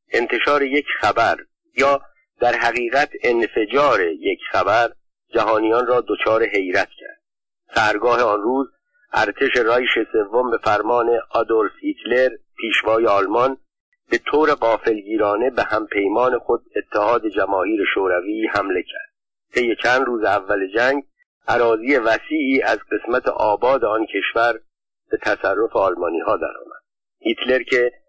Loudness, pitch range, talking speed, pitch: -19 LUFS, 285-425 Hz, 120 wpm, 350 Hz